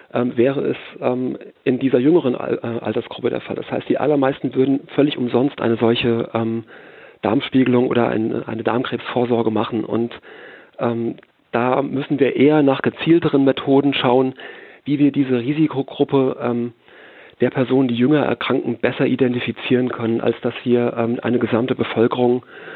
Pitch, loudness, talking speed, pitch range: 125 Hz, -19 LUFS, 130 wpm, 115-135 Hz